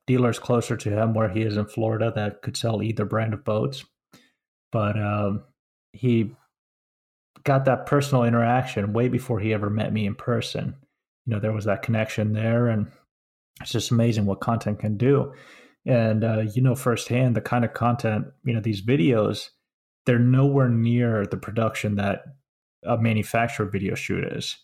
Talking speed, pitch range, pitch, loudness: 170 wpm, 105-120 Hz, 115 Hz, -24 LUFS